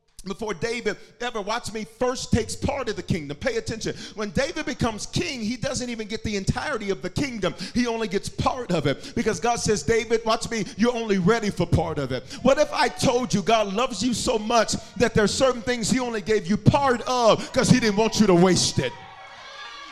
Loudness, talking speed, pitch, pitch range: -24 LUFS, 225 wpm, 225 Hz, 200-245 Hz